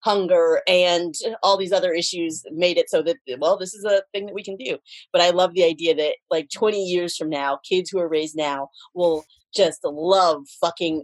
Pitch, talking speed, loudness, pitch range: 180 Hz, 210 wpm, -21 LUFS, 160-195 Hz